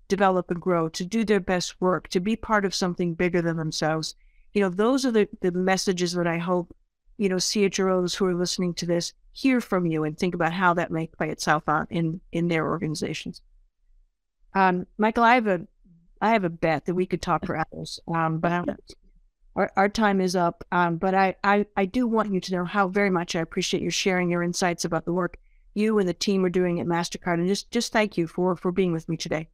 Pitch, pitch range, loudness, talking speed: 180 Hz, 170-195 Hz, -25 LUFS, 230 wpm